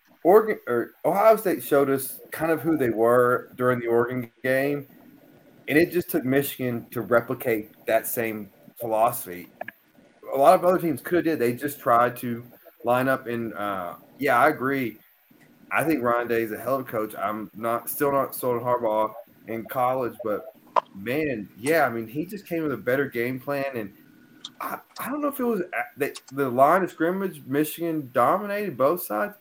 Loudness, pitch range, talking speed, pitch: -24 LUFS, 120-160 Hz, 190 wpm, 130 Hz